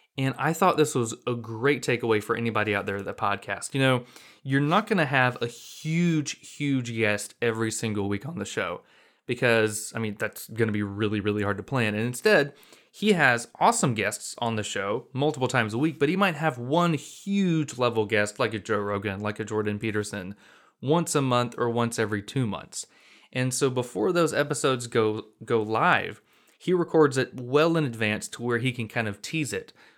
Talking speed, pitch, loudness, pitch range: 205 wpm, 120 Hz, -26 LUFS, 110-145 Hz